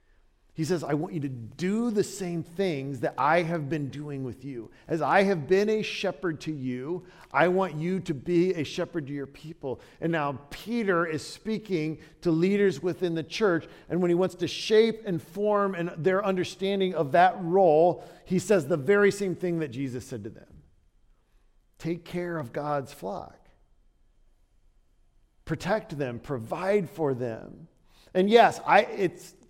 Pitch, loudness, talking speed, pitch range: 170 Hz, -27 LUFS, 170 wpm, 150-190 Hz